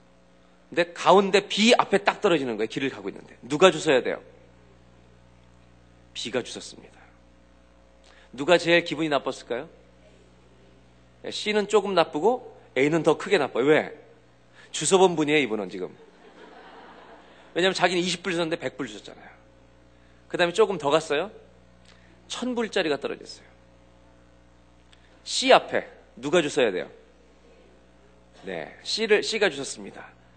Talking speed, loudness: 265 characters per minute, -24 LUFS